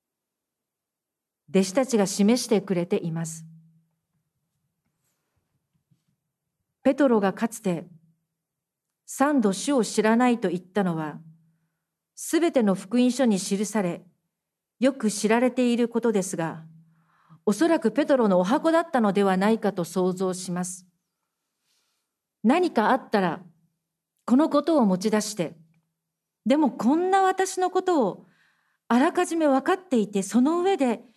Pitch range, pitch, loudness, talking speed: 170-255 Hz, 205 Hz, -24 LUFS, 240 characters per minute